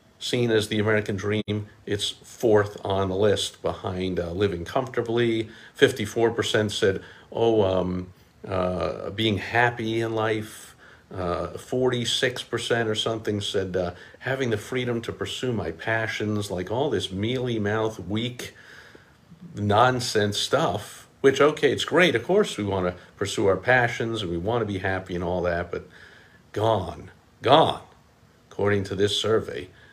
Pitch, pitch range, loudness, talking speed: 105 Hz, 95-115 Hz, -25 LUFS, 145 wpm